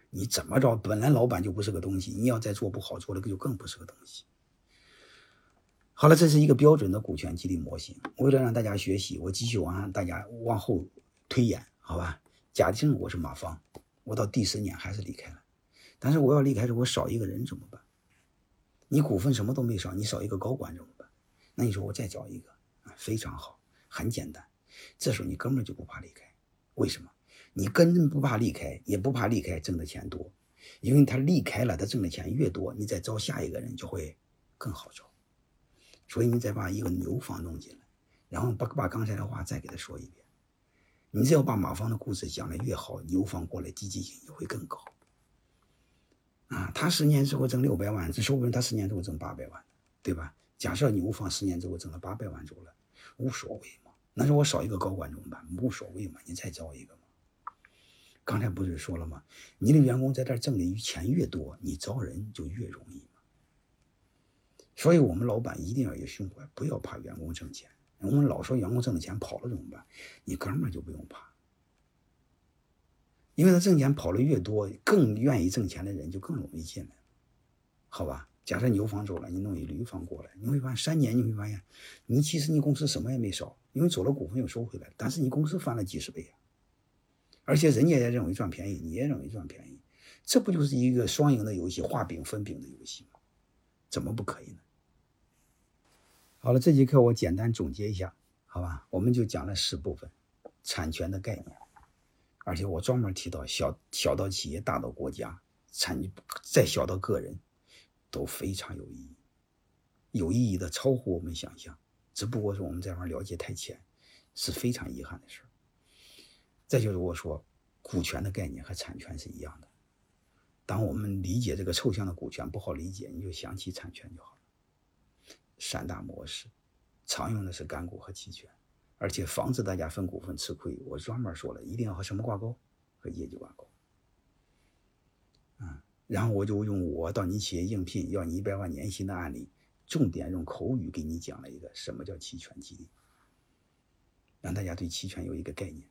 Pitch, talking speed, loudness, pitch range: 105 Hz, 290 characters per minute, -30 LUFS, 90-125 Hz